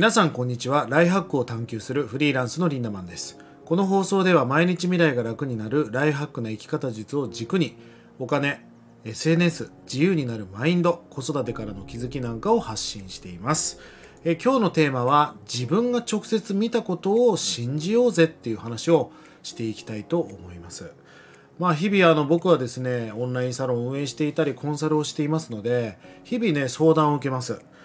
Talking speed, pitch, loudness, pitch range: 395 characters per minute, 145 Hz, -24 LUFS, 115-170 Hz